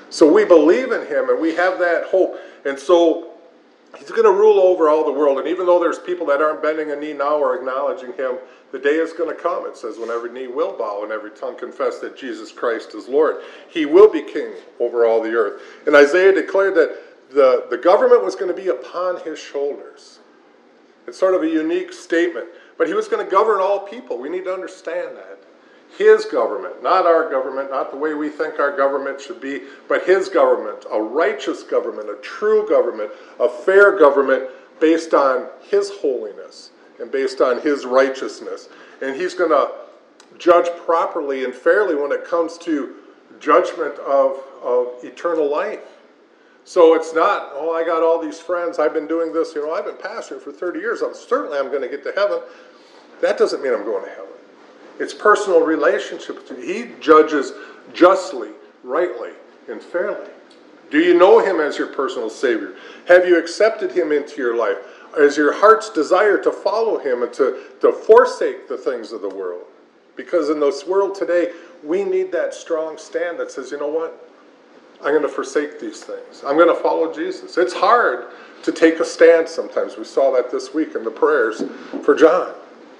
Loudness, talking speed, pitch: -18 LUFS, 195 wpm, 375 Hz